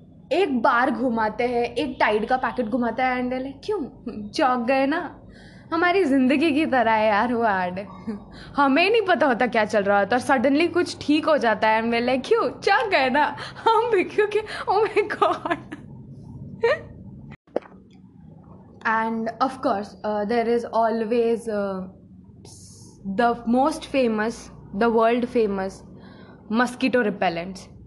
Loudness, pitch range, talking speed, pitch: -22 LUFS, 215-290 Hz, 135 wpm, 240 Hz